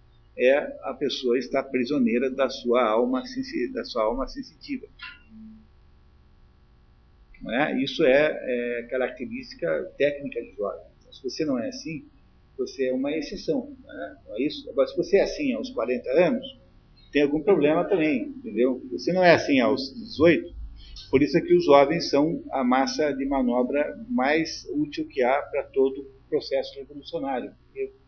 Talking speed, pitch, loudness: 150 wpm, 150 Hz, -25 LUFS